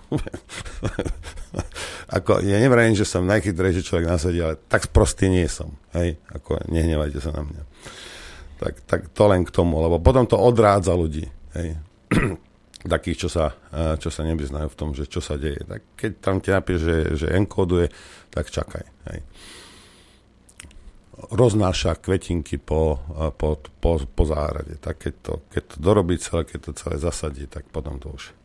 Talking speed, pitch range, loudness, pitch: 160 wpm, 75-95 Hz, -23 LUFS, 85 Hz